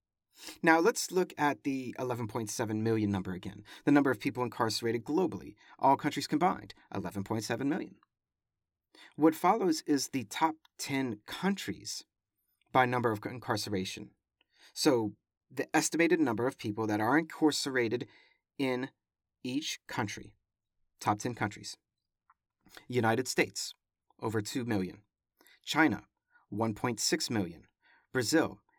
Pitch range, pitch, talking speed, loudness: 105-140 Hz, 120 Hz, 115 wpm, -32 LUFS